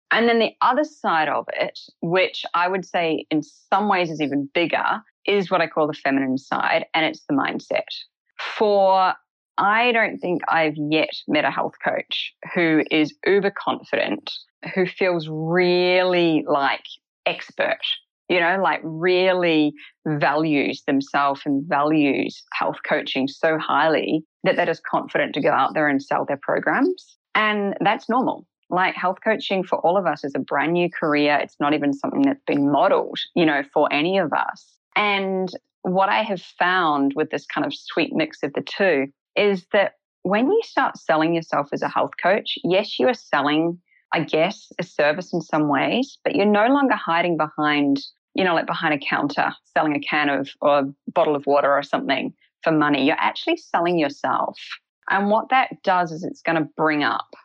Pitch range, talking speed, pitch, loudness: 150-200 Hz, 180 wpm, 170 Hz, -21 LUFS